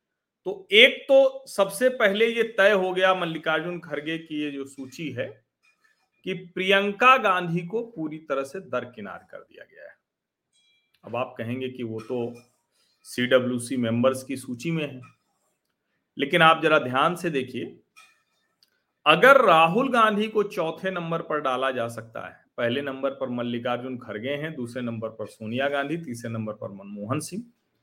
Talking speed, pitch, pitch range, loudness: 155 wpm, 155 Hz, 125-195 Hz, -23 LUFS